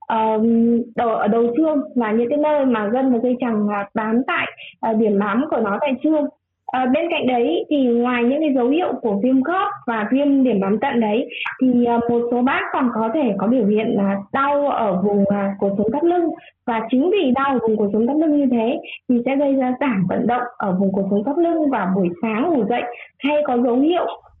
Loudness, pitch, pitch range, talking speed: -19 LUFS, 245 Hz, 225-285 Hz, 235 wpm